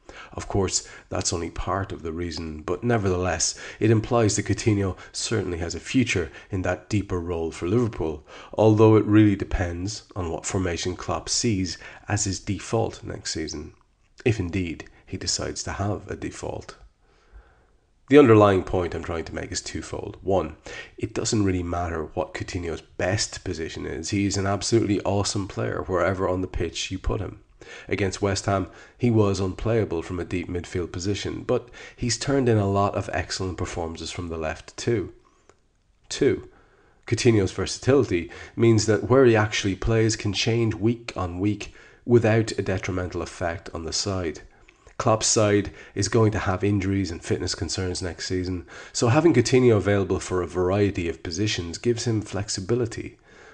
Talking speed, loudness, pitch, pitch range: 165 wpm, -24 LUFS, 100 Hz, 90-110 Hz